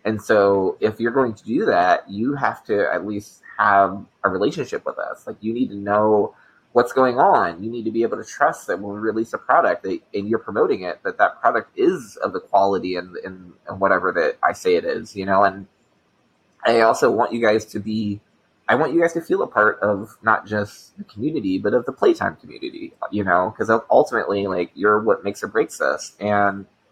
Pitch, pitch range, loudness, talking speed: 110 Hz, 100-130 Hz, -20 LUFS, 220 wpm